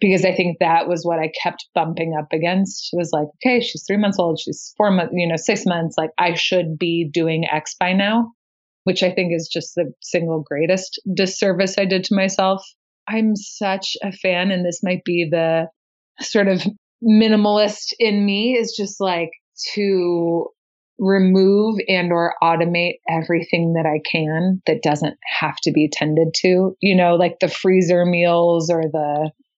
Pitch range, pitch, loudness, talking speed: 165-195 Hz, 180 Hz, -19 LUFS, 180 wpm